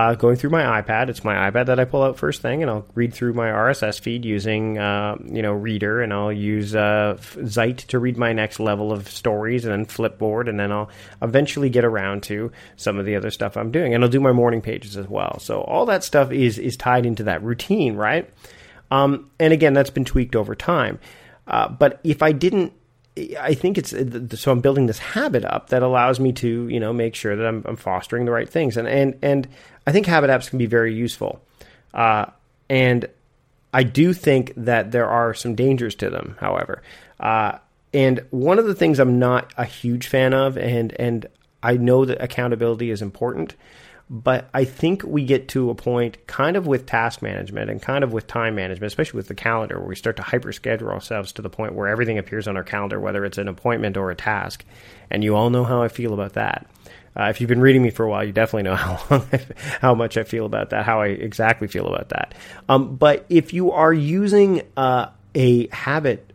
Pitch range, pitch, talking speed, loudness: 105-130 Hz, 120 Hz, 225 wpm, -20 LUFS